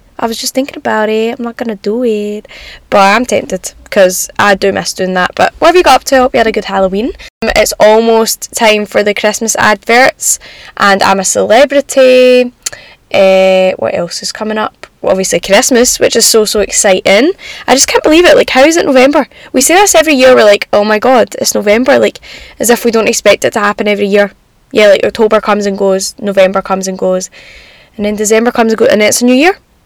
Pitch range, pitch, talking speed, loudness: 205-255 Hz, 220 Hz, 230 wpm, -8 LUFS